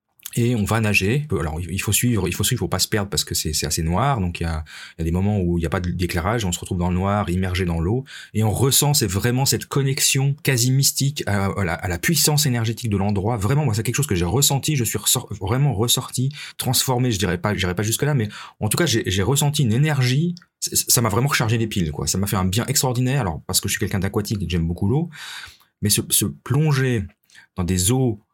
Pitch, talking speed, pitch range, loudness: 110 Hz, 260 wpm, 95-130 Hz, -20 LUFS